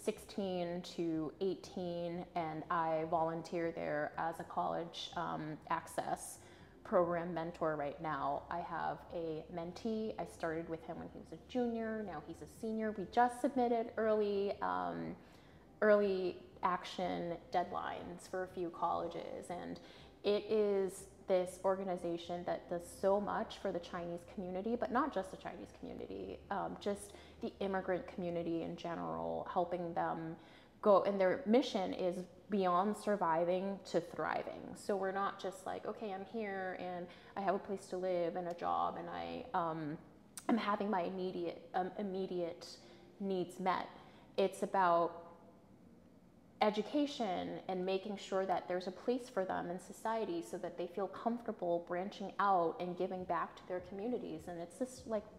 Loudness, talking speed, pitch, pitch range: -39 LUFS, 155 wpm, 185 Hz, 170-205 Hz